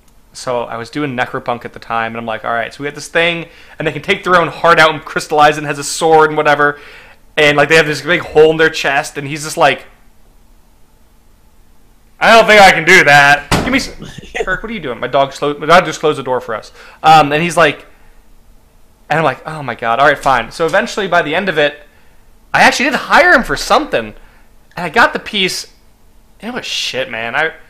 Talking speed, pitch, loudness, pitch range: 240 wpm, 150 Hz, -12 LUFS, 140-165 Hz